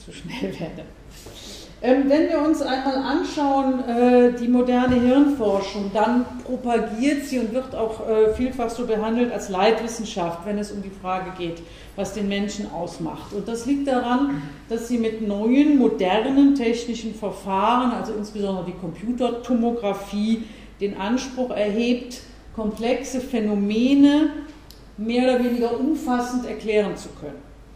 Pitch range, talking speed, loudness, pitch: 210-255 Hz, 130 wpm, -22 LUFS, 235 Hz